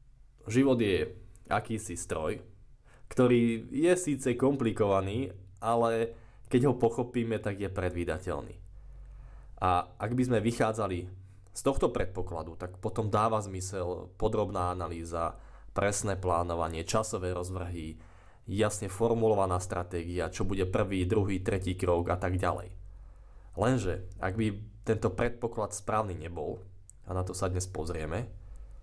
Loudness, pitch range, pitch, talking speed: -31 LUFS, 90-115 Hz, 100 Hz, 120 wpm